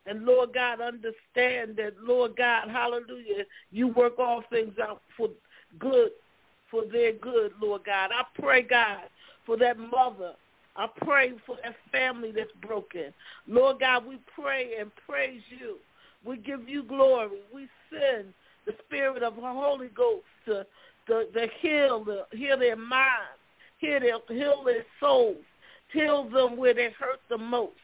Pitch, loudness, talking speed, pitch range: 245 Hz, -27 LUFS, 155 wpm, 230-270 Hz